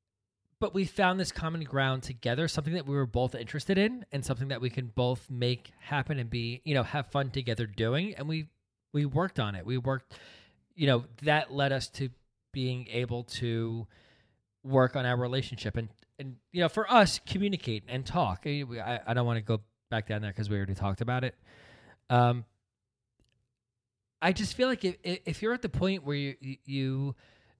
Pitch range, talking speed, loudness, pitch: 115-145 Hz, 195 wpm, -31 LUFS, 125 Hz